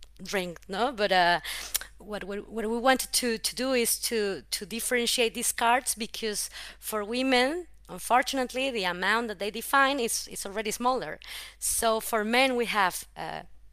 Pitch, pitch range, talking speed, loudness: 225 Hz, 200-245 Hz, 160 wpm, -27 LUFS